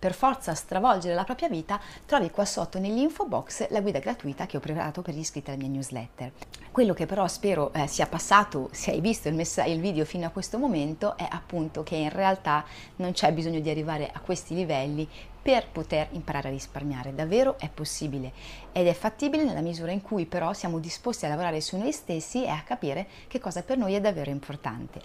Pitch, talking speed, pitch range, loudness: 170 Hz, 200 wpm, 150-200 Hz, -28 LUFS